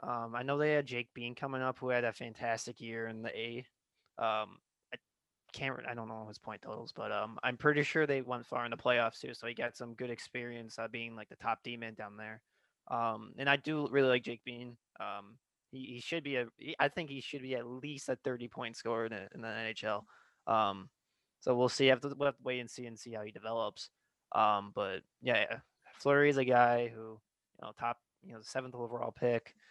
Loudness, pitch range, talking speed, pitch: -36 LUFS, 115-130 Hz, 230 wpm, 120 Hz